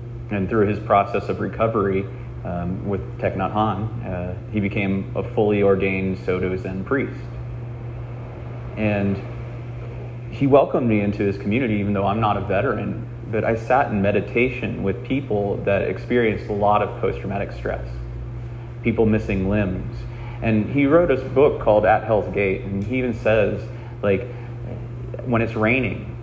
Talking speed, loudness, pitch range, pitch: 155 wpm, -22 LUFS, 100-120 Hz, 110 Hz